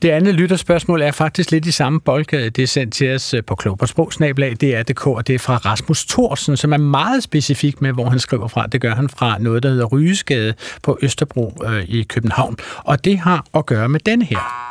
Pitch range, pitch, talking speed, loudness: 120-155 Hz, 140 Hz, 215 wpm, -17 LUFS